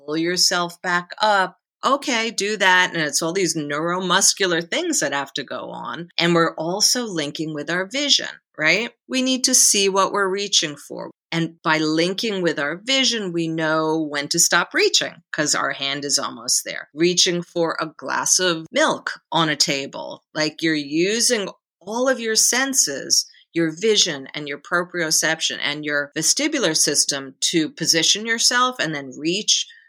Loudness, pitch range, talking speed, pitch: -19 LUFS, 155-215 Hz, 165 wpm, 175 Hz